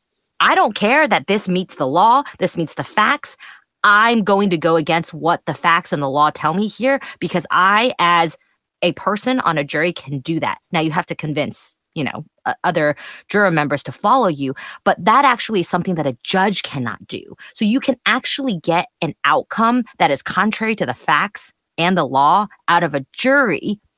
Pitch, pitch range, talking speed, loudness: 180 Hz, 165-215 Hz, 200 wpm, -17 LUFS